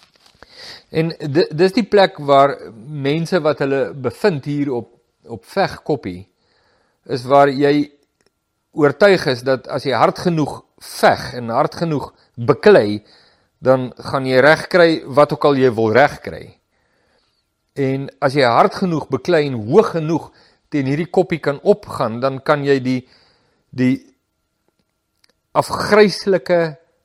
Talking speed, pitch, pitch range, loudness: 130 wpm, 145 Hz, 130-165 Hz, -16 LUFS